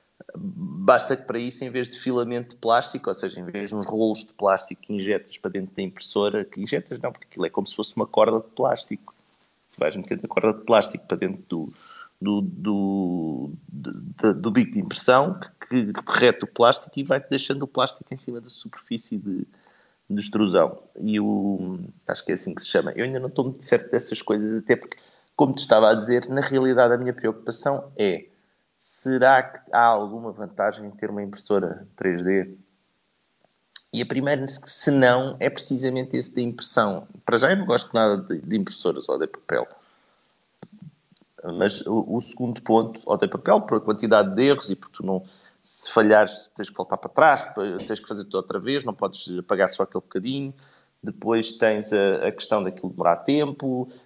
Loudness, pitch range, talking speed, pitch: -23 LUFS, 105-135 Hz, 195 wpm, 120 Hz